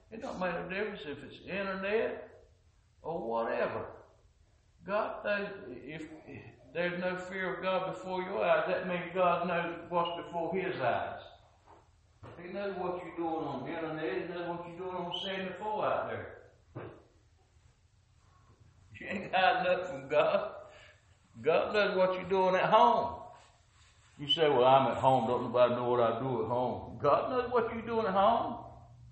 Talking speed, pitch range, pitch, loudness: 170 wpm, 115-185 Hz, 165 Hz, -32 LUFS